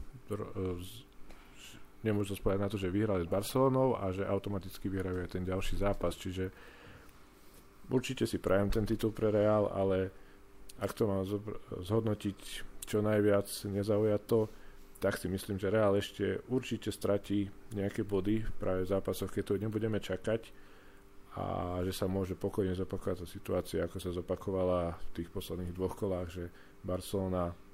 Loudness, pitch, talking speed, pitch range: -35 LUFS, 100 Hz, 145 wpm, 95-105 Hz